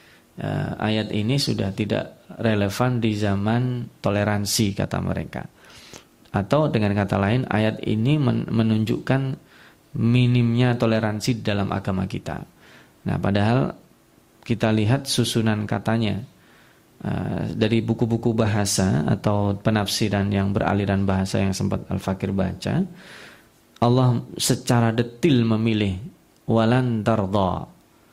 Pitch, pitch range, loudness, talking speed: 110 Hz, 100-120 Hz, -22 LUFS, 100 wpm